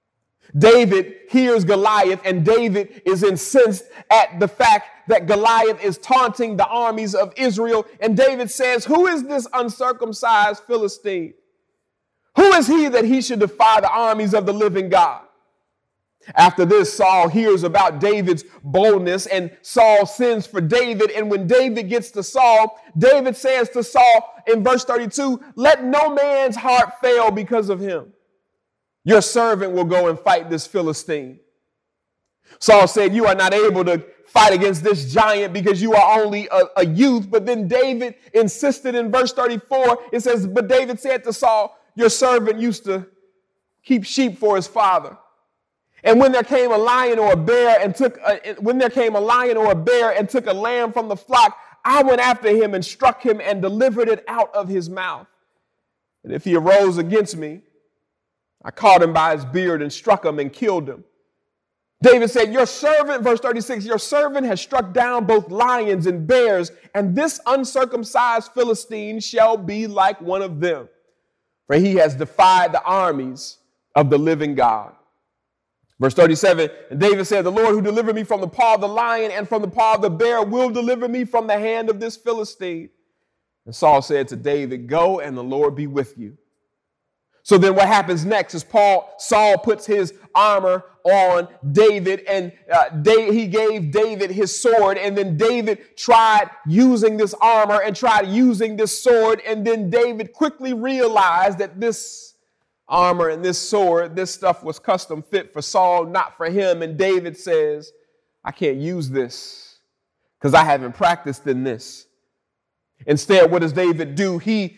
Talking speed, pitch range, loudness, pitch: 175 wpm, 185-240 Hz, -17 LUFS, 215 Hz